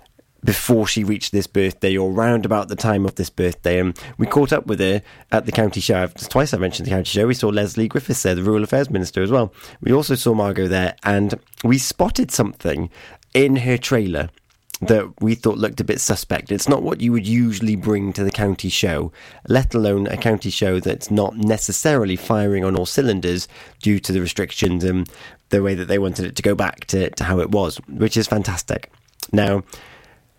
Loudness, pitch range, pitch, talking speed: -19 LUFS, 95-115 Hz, 105 Hz, 205 wpm